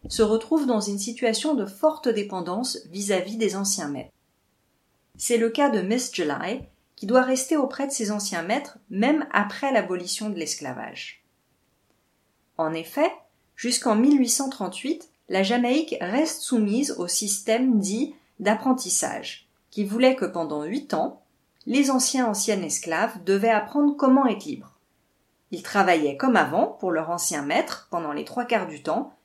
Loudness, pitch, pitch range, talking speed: -24 LUFS, 225 Hz, 195-260 Hz, 150 wpm